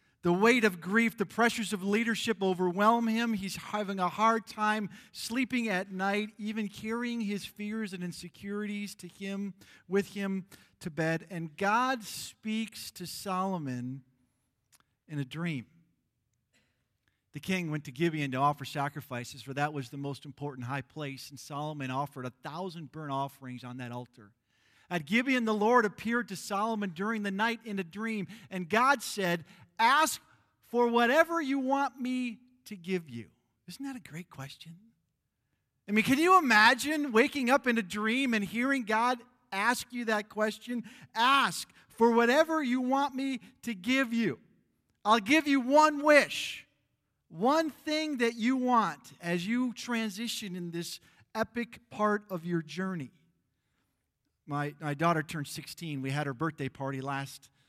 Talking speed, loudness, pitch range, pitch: 155 wpm, -30 LUFS, 155-235 Hz, 200 Hz